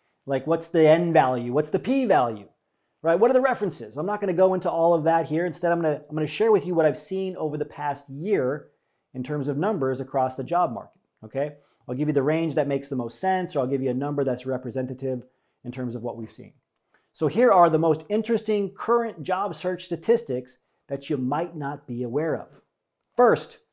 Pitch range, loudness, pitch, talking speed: 130-180 Hz, -24 LUFS, 155 Hz, 235 wpm